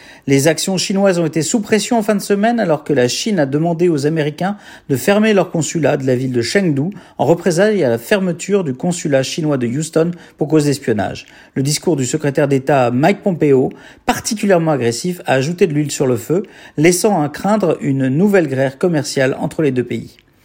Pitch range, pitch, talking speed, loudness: 140-190 Hz, 155 Hz, 200 wpm, -16 LUFS